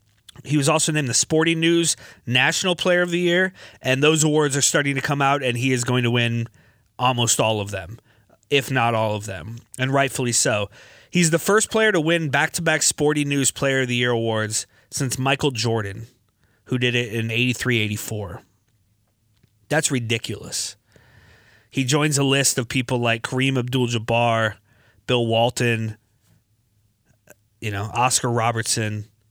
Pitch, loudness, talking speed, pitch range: 120 Hz, -20 LUFS, 165 wpm, 110-140 Hz